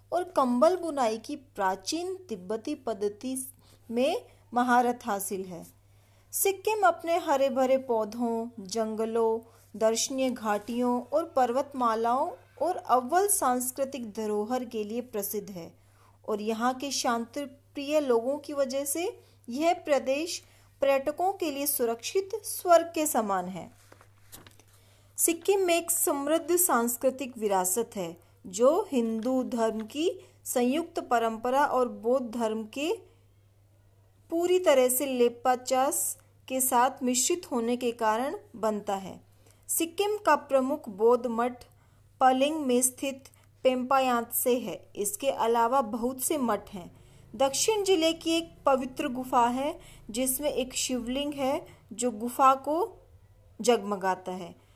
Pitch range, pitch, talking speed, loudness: 220-290 Hz, 250 Hz, 120 wpm, -28 LUFS